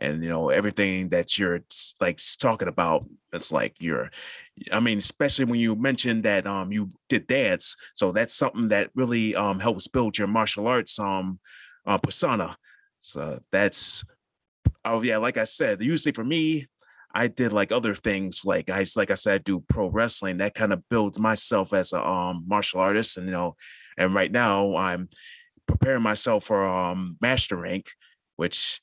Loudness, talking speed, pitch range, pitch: -24 LUFS, 175 wpm, 95-115 Hz, 100 Hz